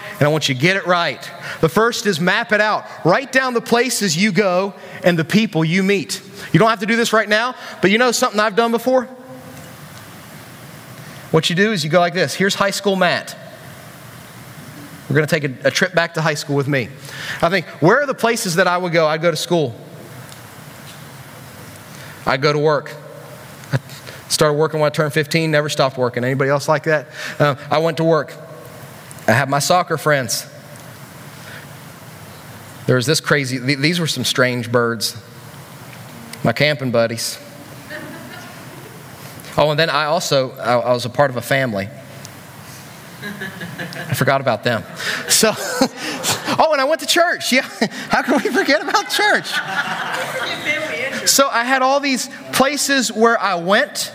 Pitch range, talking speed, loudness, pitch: 140-200 Hz, 175 wpm, -17 LUFS, 155 Hz